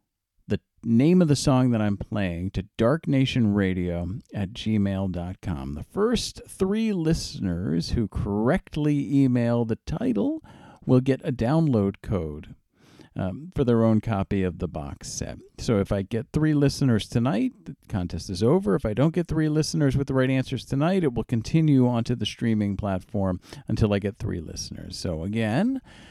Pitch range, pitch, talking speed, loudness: 100-145 Hz, 115 Hz, 160 wpm, -25 LUFS